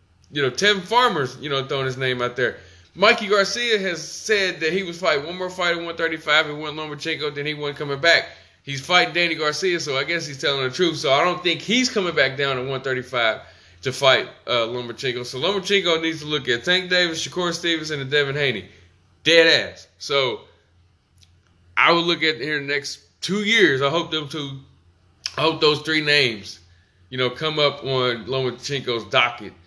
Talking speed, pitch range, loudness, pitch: 205 wpm, 125-170 Hz, -20 LUFS, 150 Hz